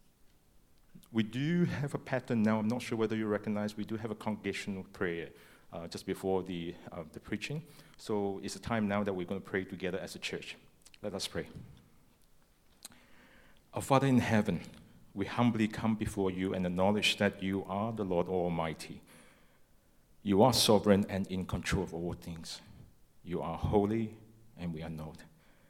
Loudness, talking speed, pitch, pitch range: -33 LUFS, 175 wpm, 100 Hz, 90-110 Hz